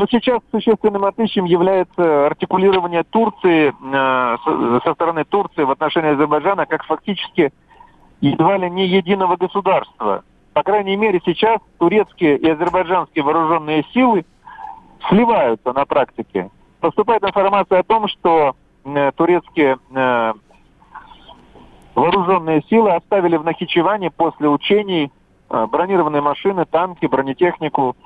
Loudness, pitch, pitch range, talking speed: -17 LUFS, 175 Hz, 155-200 Hz, 110 wpm